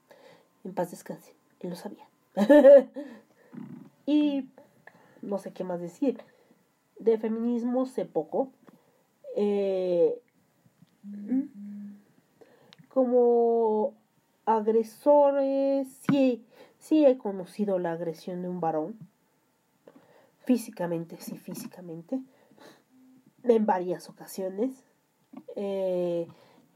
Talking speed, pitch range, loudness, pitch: 80 wpm, 185-260 Hz, -26 LUFS, 225 Hz